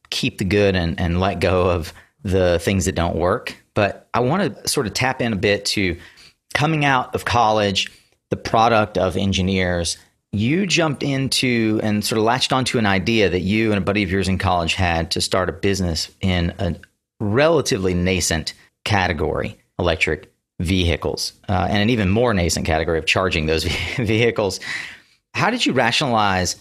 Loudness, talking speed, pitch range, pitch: -19 LUFS, 175 wpm, 90-110 Hz, 95 Hz